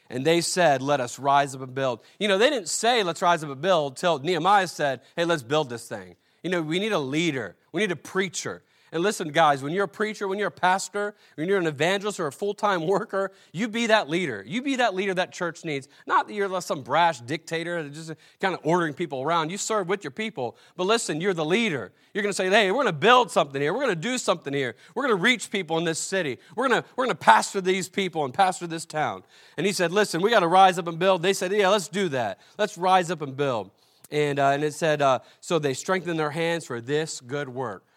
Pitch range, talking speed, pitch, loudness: 150-195 Hz, 260 wpm, 175 Hz, -24 LUFS